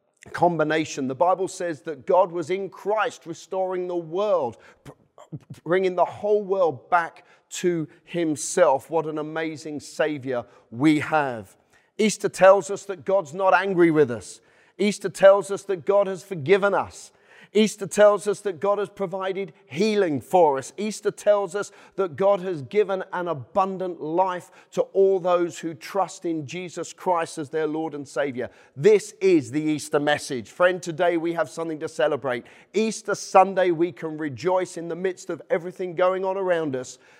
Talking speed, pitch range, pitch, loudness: 165 wpm, 155-195 Hz, 180 Hz, -23 LUFS